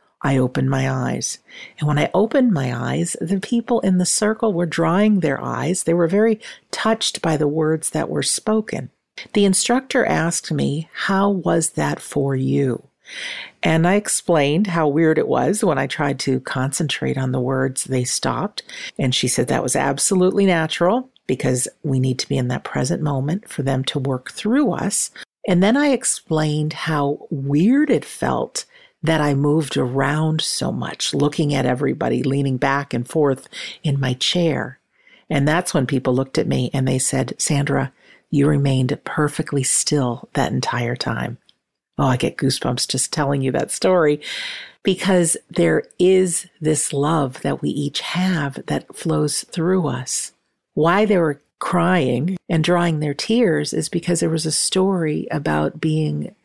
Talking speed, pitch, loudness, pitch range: 165 wpm, 155 Hz, -20 LUFS, 135-180 Hz